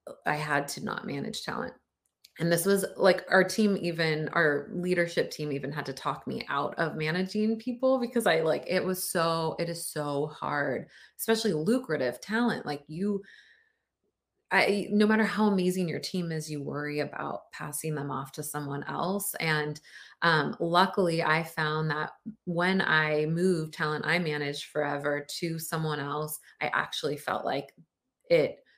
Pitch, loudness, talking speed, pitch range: 165 Hz, -29 LUFS, 165 wpm, 150-195 Hz